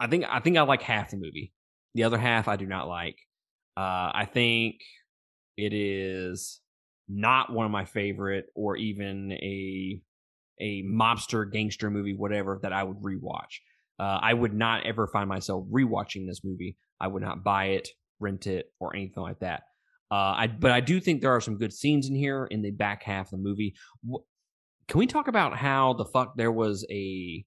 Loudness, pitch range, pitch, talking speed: -28 LUFS, 95-115 Hz, 105 Hz, 195 wpm